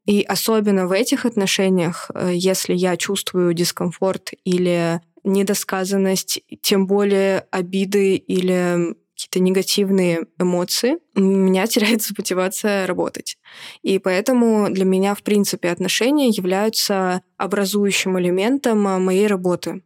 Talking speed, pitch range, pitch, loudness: 105 wpm, 185-205 Hz, 190 Hz, -19 LUFS